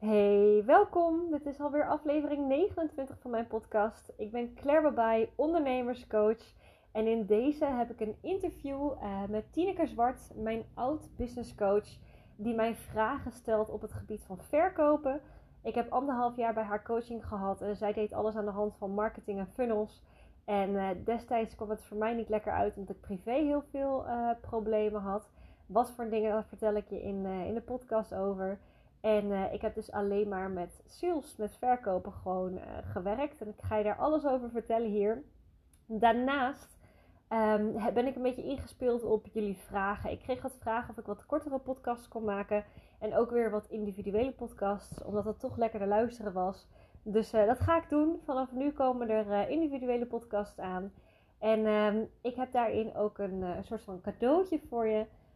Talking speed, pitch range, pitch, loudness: 185 wpm, 210-255 Hz, 225 Hz, -33 LUFS